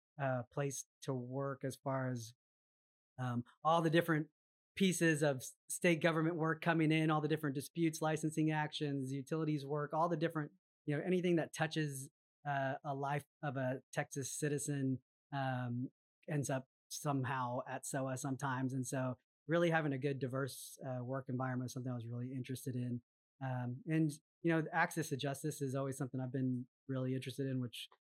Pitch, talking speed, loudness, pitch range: 140 Hz, 175 wpm, -39 LUFS, 130-155 Hz